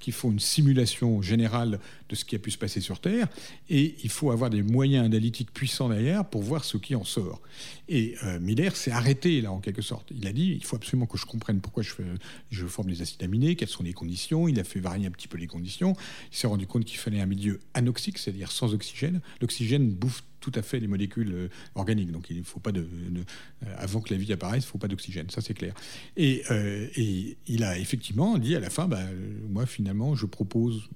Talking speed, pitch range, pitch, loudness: 235 wpm, 100-130 Hz, 110 Hz, -29 LUFS